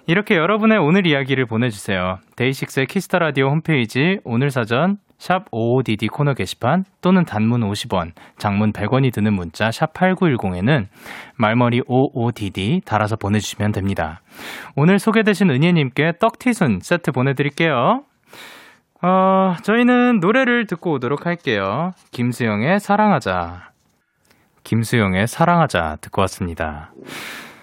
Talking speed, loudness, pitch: 295 characters per minute, -18 LUFS, 135 Hz